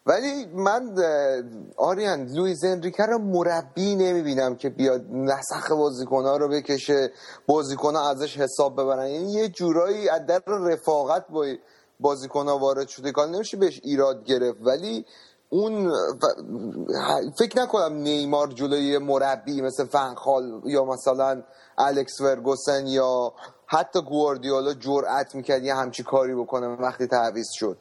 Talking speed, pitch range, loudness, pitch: 125 wpm, 135-165 Hz, -24 LUFS, 140 Hz